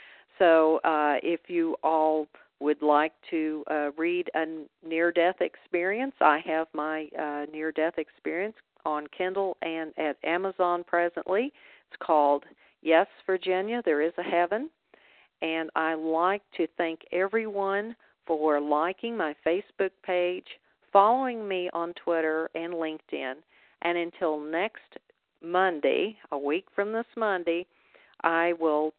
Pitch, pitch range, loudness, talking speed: 170 Hz, 155-185 Hz, -28 LUFS, 130 wpm